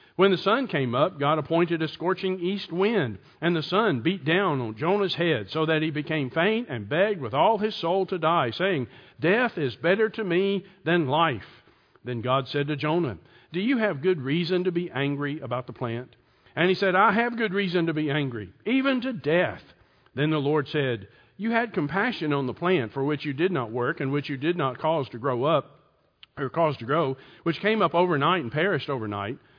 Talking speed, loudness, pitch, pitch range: 215 wpm, -25 LUFS, 160 Hz, 135-185 Hz